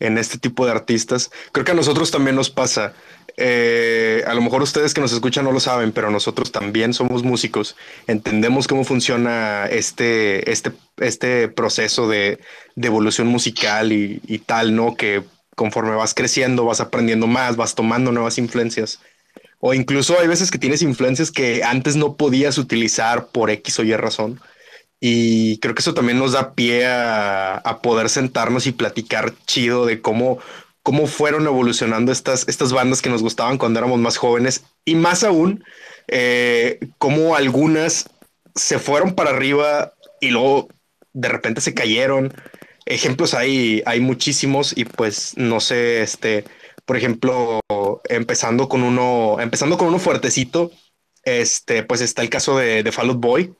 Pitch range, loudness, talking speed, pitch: 115-135 Hz, -18 LUFS, 160 wpm, 125 Hz